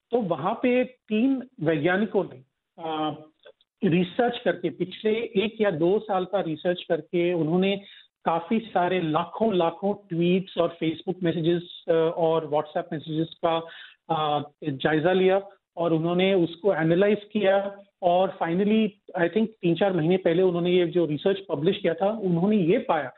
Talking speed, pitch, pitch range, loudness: 140 wpm, 180 Hz, 165-200 Hz, -25 LUFS